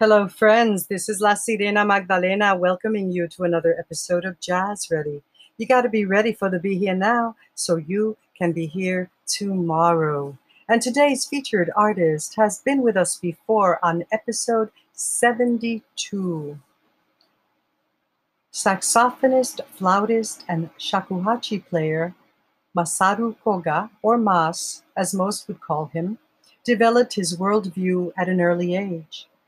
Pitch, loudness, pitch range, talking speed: 195 Hz, -21 LUFS, 175-220 Hz, 130 wpm